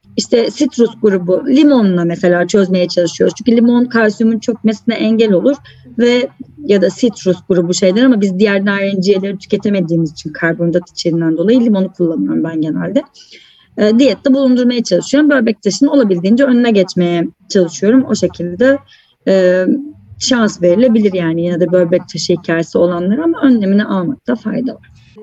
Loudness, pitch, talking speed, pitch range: -13 LUFS, 205 Hz, 140 wpm, 180-245 Hz